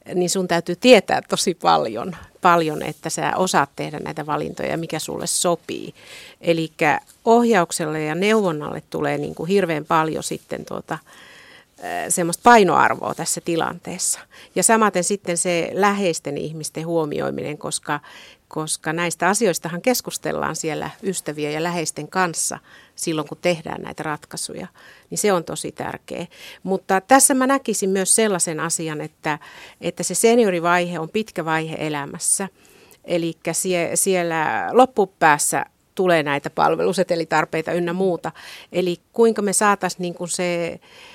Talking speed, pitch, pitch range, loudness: 130 wpm, 175 Hz, 160-195 Hz, -20 LUFS